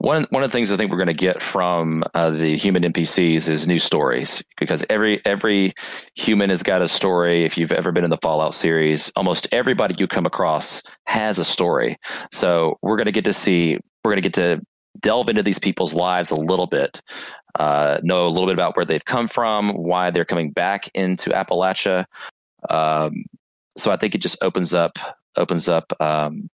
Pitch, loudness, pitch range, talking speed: 90 Hz, -19 LUFS, 80-95 Hz, 205 wpm